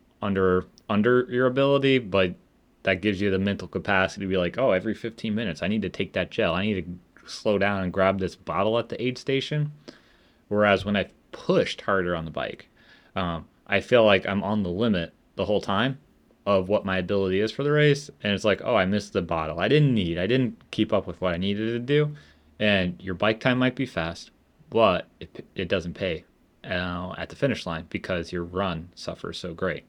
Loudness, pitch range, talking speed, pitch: -25 LUFS, 90-120 Hz, 215 wpm, 100 Hz